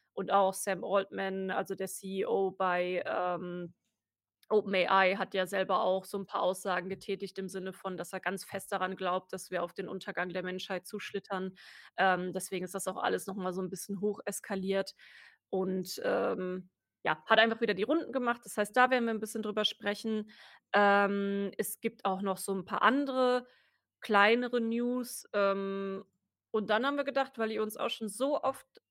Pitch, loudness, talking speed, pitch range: 195 Hz, -32 LUFS, 185 wpm, 190-215 Hz